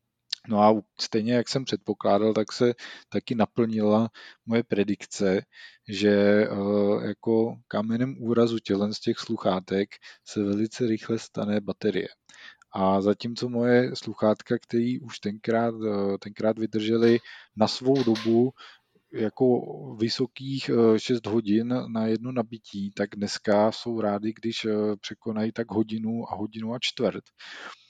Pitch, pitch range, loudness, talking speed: 110 Hz, 105-115 Hz, -26 LUFS, 120 wpm